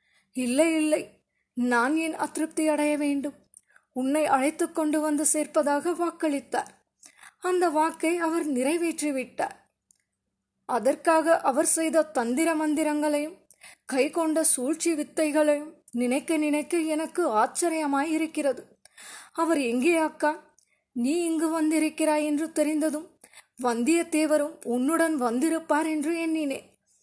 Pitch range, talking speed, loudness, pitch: 290-325 Hz, 95 wpm, -26 LUFS, 310 Hz